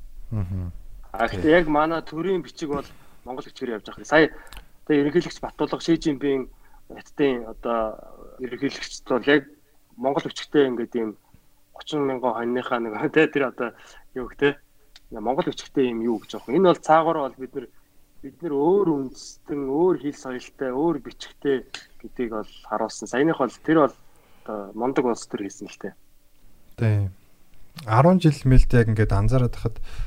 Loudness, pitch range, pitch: -23 LUFS, 115-150 Hz, 130 Hz